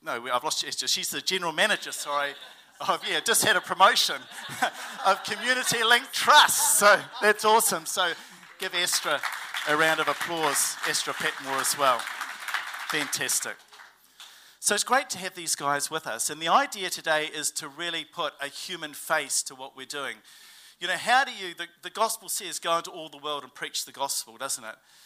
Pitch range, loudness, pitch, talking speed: 145-205 Hz, -25 LUFS, 170 Hz, 185 wpm